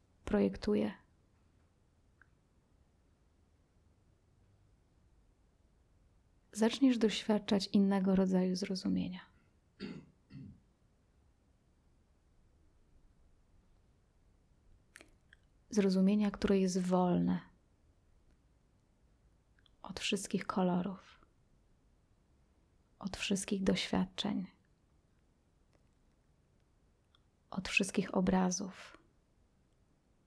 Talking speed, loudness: 40 wpm, -34 LUFS